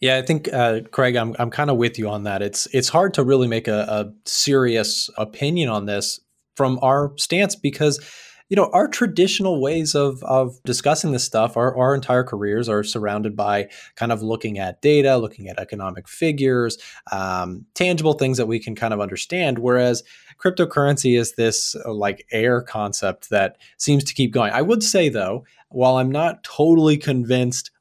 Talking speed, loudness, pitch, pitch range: 185 wpm, -20 LUFS, 125 Hz, 110-145 Hz